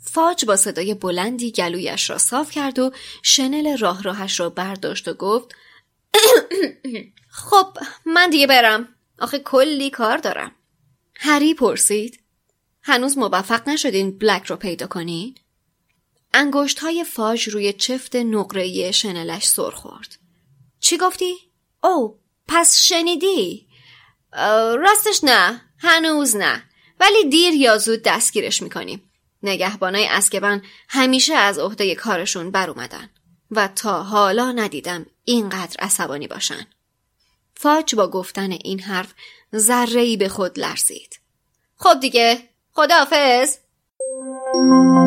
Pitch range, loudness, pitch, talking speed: 195-290 Hz, -17 LUFS, 240 Hz, 110 wpm